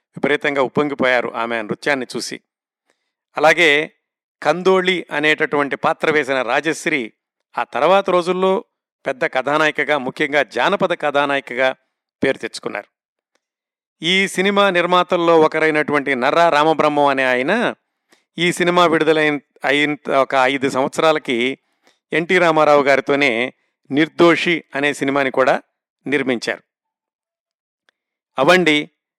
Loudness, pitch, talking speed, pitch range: -17 LUFS, 150 Hz, 95 wpm, 140-175 Hz